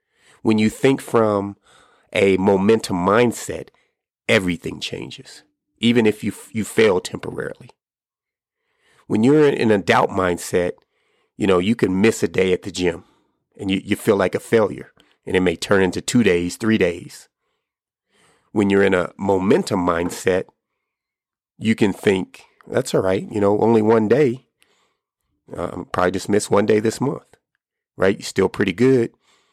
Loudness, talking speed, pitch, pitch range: -19 LUFS, 160 wpm, 105 Hz, 95-115 Hz